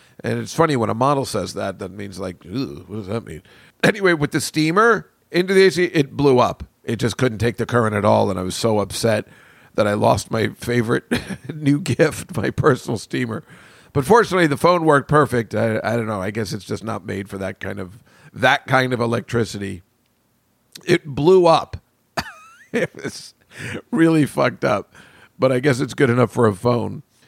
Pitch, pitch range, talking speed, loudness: 120 Hz, 105-145 Hz, 195 wpm, -19 LUFS